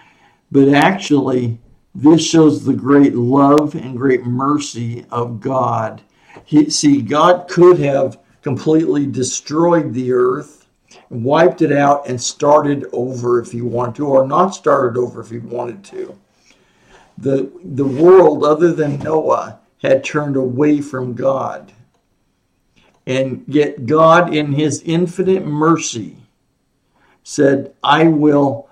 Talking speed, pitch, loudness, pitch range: 125 wpm, 140 Hz, -14 LUFS, 125-155 Hz